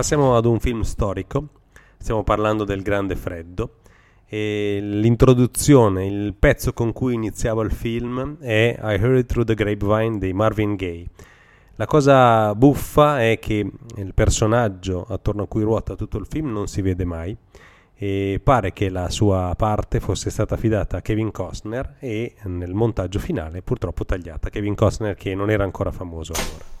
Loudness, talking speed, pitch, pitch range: -21 LUFS, 160 wpm, 105 Hz, 95-115 Hz